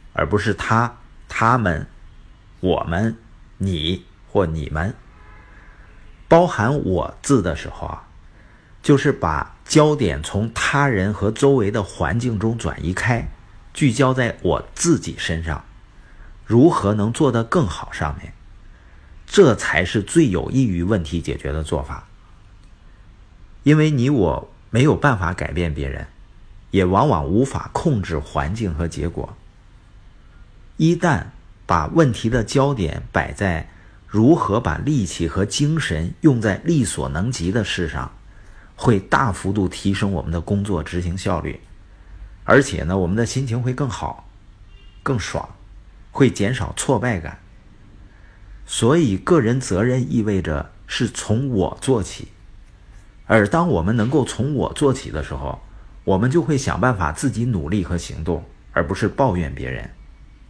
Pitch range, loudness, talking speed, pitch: 85-115 Hz, -20 LUFS, 200 characters per minute, 100 Hz